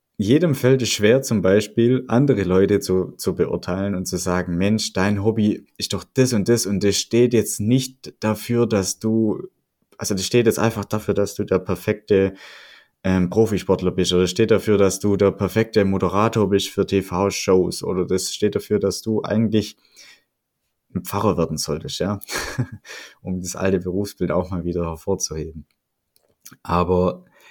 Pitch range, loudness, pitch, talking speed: 95-110 Hz, -20 LUFS, 100 Hz, 165 wpm